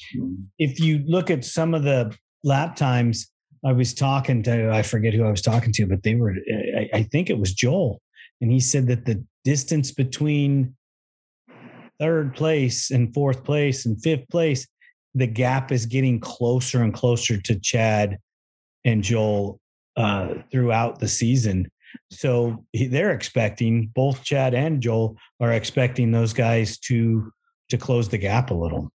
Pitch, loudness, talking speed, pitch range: 120 Hz, -22 LUFS, 155 wpm, 110-135 Hz